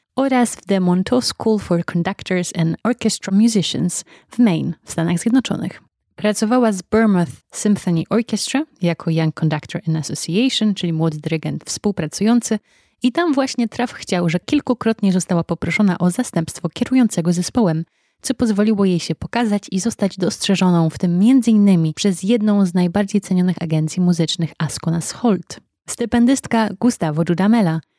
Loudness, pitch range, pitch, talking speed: -18 LUFS, 170-225 Hz, 195 Hz, 140 wpm